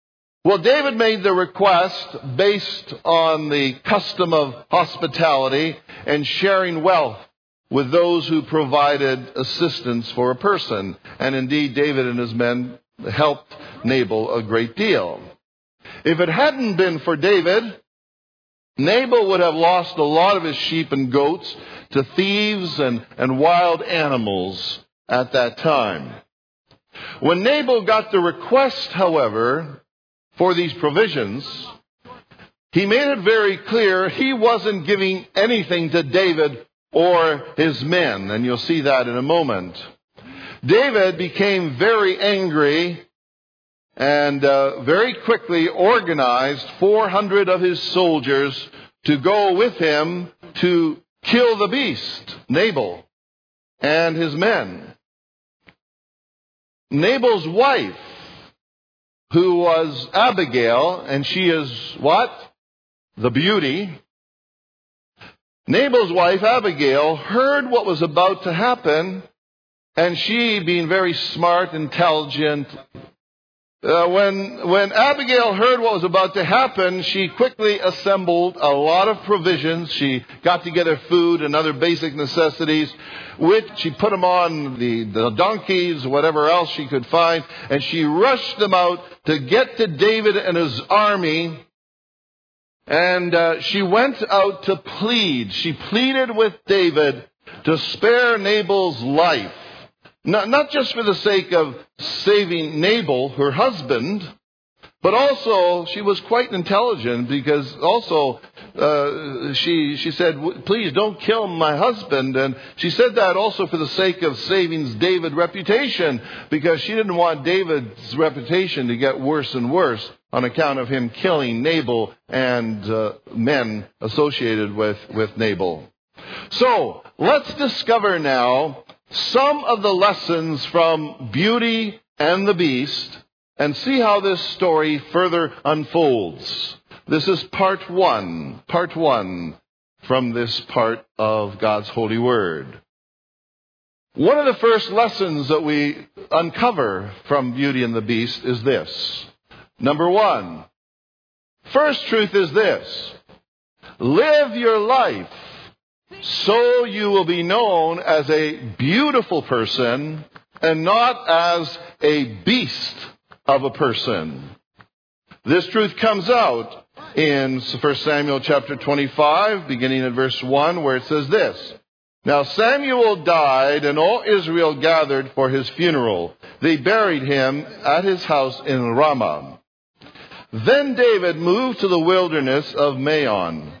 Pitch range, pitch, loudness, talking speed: 140-200 Hz, 165 Hz, -18 LUFS, 125 wpm